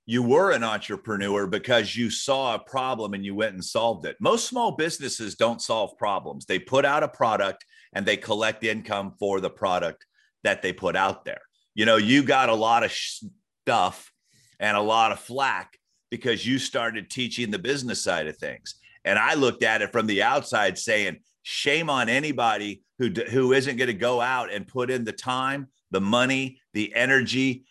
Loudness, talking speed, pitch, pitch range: -24 LUFS, 195 wpm, 115 Hz, 105-130 Hz